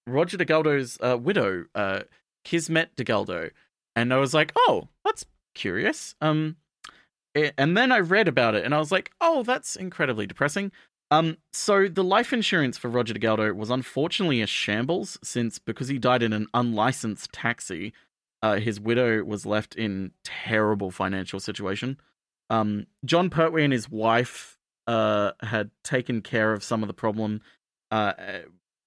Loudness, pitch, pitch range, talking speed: -25 LUFS, 125 Hz, 110-160 Hz, 155 wpm